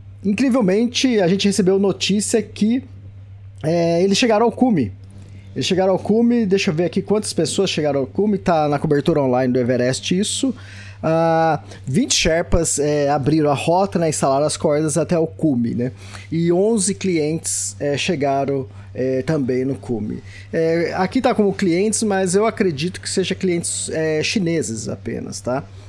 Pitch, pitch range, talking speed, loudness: 160 Hz, 130-195 Hz, 160 wpm, -19 LUFS